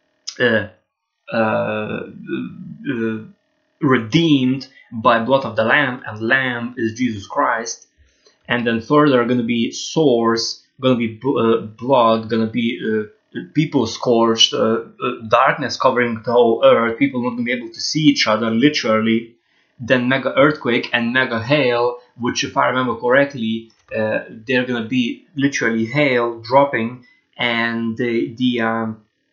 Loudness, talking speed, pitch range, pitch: -18 LUFS, 140 wpm, 115-135 Hz, 120 Hz